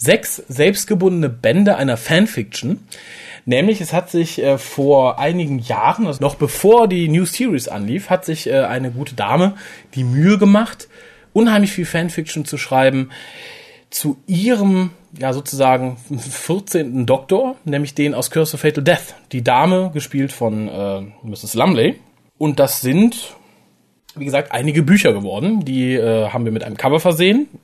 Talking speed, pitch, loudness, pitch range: 150 wpm, 150 Hz, -16 LUFS, 130-185 Hz